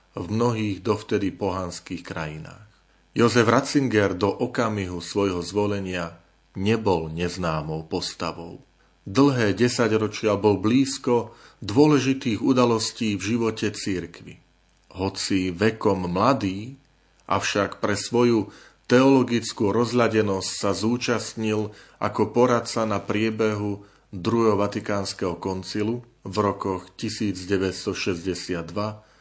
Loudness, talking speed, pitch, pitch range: -24 LUFS, 90 wpm, 105 Hz, 95-115 Hz